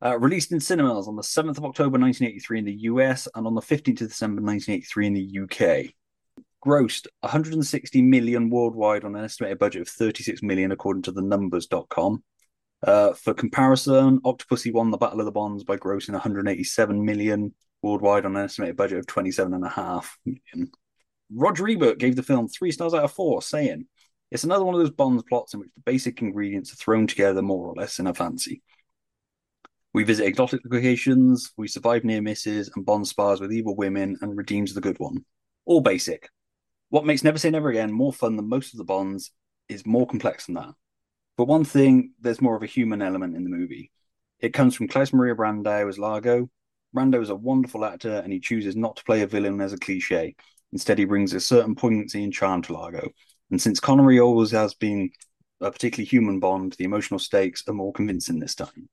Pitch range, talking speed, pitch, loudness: 100-130 Hz, 200 wpm, 115 Hz, -23 LUFS